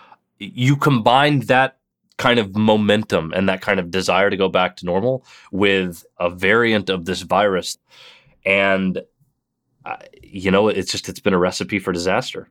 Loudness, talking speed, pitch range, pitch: -18 LUFS, 160 wpm, 95-125 Hz, 105 Hz